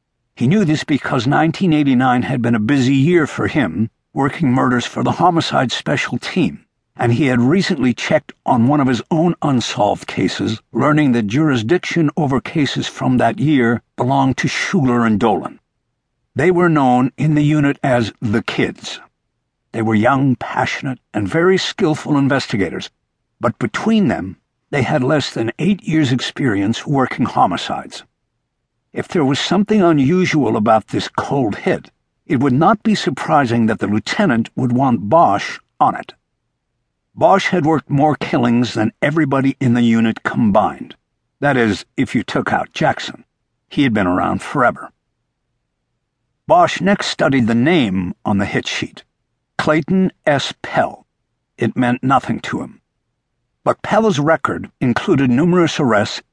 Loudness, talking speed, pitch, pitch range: -16 LUFS, 150 wpm, 135 Hz, 120-155 Hz